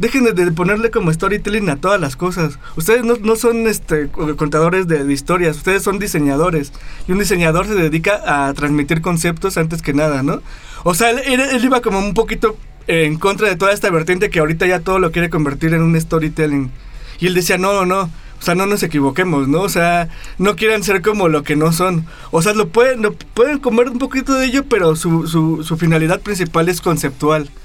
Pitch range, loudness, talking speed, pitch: 160-205 Hz, -15 LUFS, 210 wpm, 180 Hz